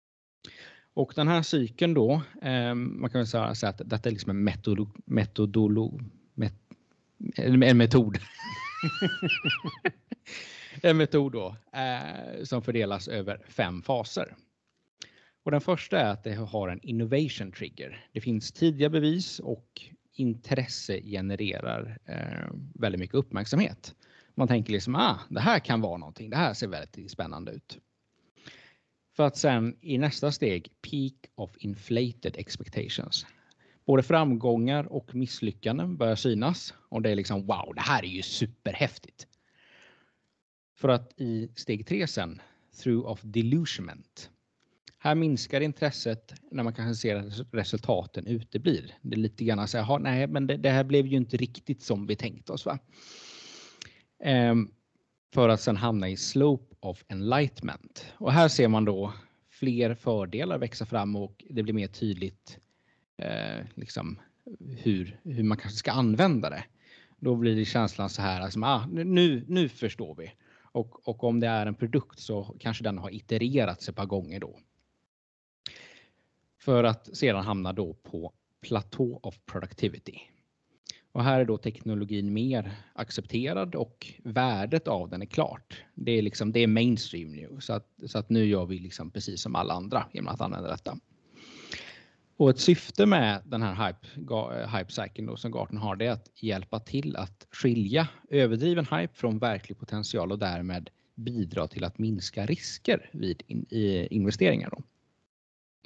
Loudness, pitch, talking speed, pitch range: -29 LUFS, 115 Hz, 150 wpm, 105-130 Hz